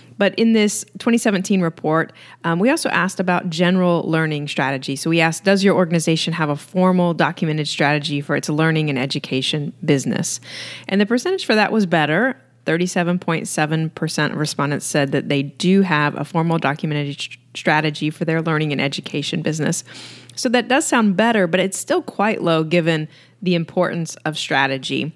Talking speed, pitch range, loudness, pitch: 170 wpm, 150-185 Hz, -19 LUFS, 165 Hz